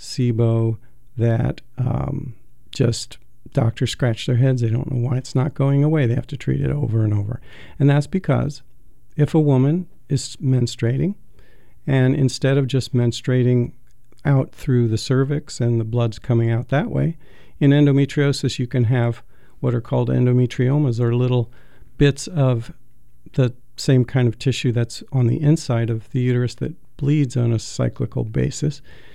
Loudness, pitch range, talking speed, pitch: -20 LUFS, 120-140 Hz, 165 wpm, 125 Hz